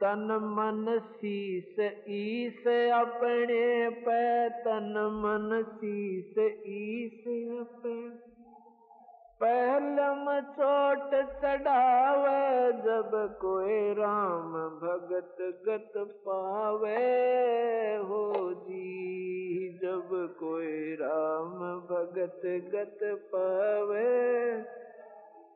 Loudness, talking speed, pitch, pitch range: -31 LUFS, 65 wpm, 215 Hz, 190-240 Hz